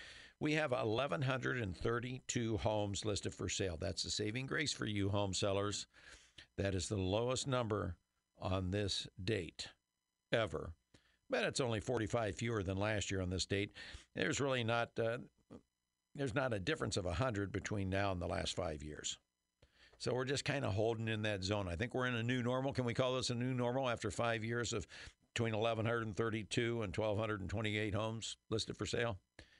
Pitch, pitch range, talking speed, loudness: 110 Hz, 100-120 Hz, 175 wpm, -39 LUFS